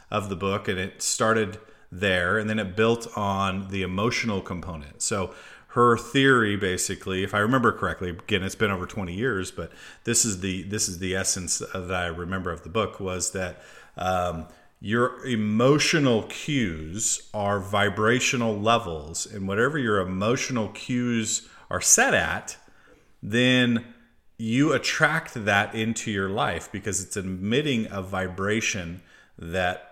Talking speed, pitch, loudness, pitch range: 150 wpm, 100 Hz, -25 LUFS, 95-115 Hz